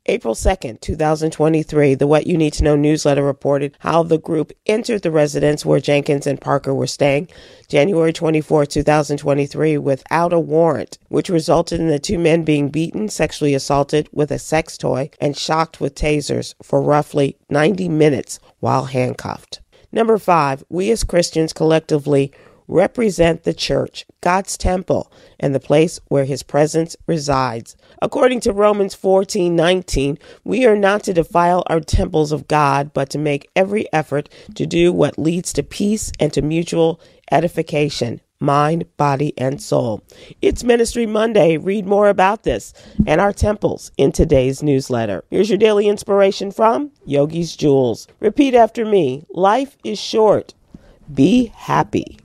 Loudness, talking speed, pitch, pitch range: -17 LUFS, 150 wpm, 155 Hz, 145-185 Hz